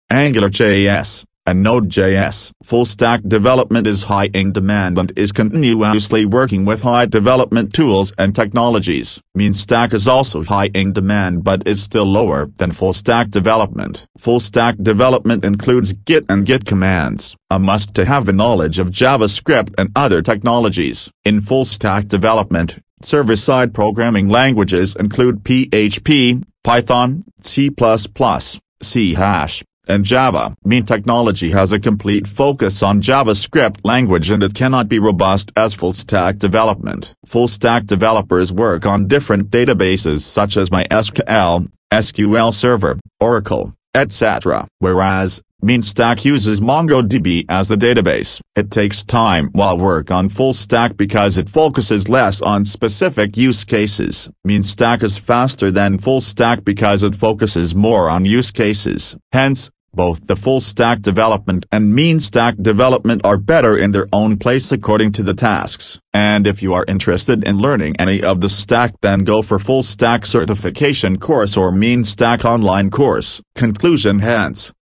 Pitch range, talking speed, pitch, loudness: 100-120 Hz, 150 wpm, 105 Hz, -14 LUFS